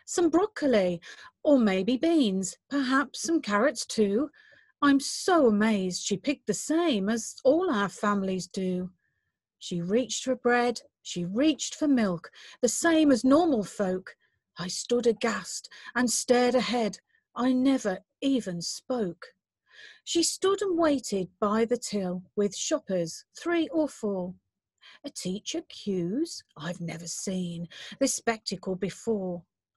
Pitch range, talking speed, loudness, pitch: 195-290 Hz, 130 wpm, -27 LUFS, 235 Hz